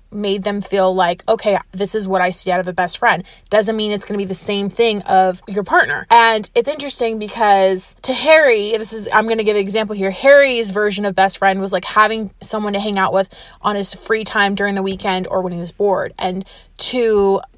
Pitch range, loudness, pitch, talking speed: 190-220 Hz, -16 LUFS, 205 Hz, 235 wpm